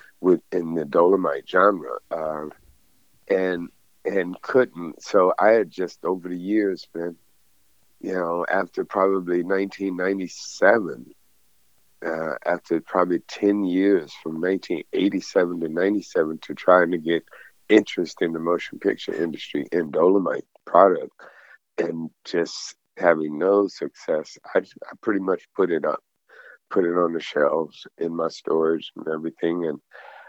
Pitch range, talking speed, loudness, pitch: 80-95 Hz, 135 wpm, -23 LUFS, 85 Hz